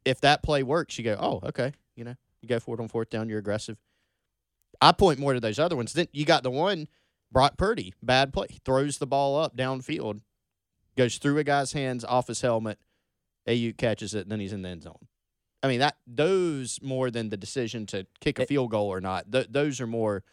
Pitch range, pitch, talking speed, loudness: 105-140 Hz, 120 Hz, 225 wpm, -27 LUFS